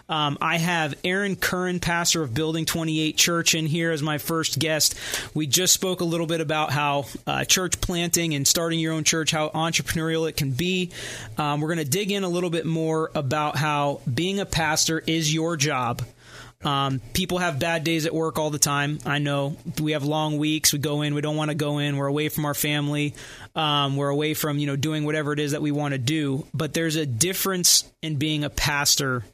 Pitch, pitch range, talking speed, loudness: 155 Hz, 145-165 Hz, 225 wpm, -23 LUFS